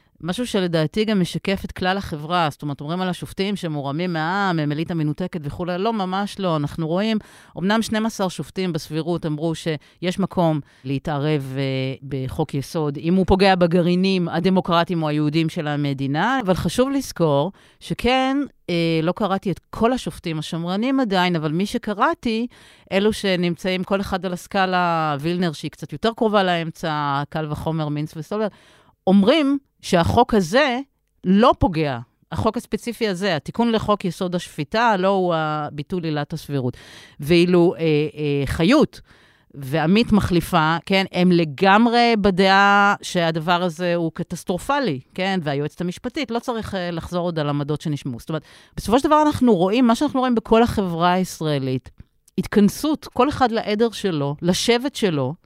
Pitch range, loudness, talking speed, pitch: 155-205 Hz, -21 LUFS, 145 wpm, 180 Hz